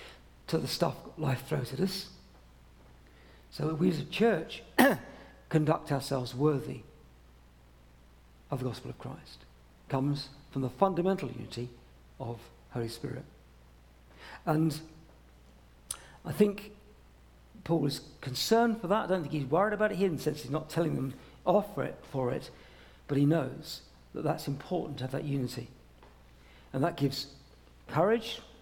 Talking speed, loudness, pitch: 145 wpm, -32 LUFS, 135 Hz